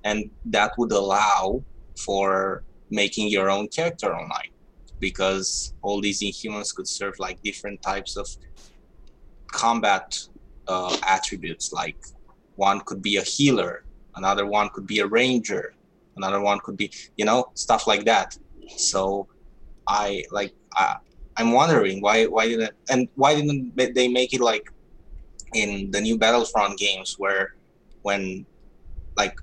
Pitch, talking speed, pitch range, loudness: 100 Hz, 140 wpm, 95-115 Hz, -23 LUFS